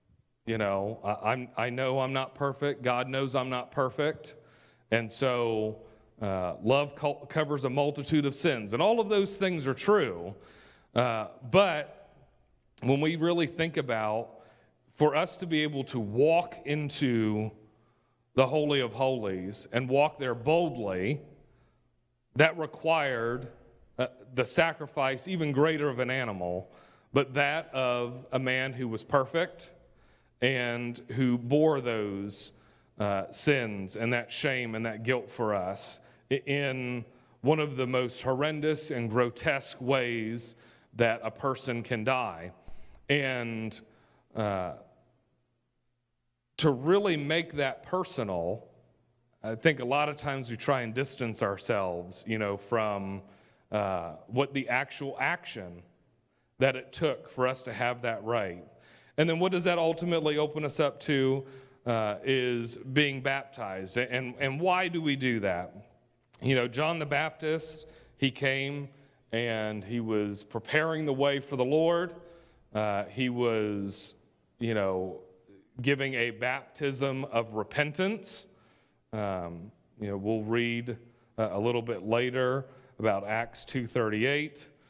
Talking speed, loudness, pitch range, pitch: 135 wpm, -30 LUFS, 115-145 Hz, 130 Hz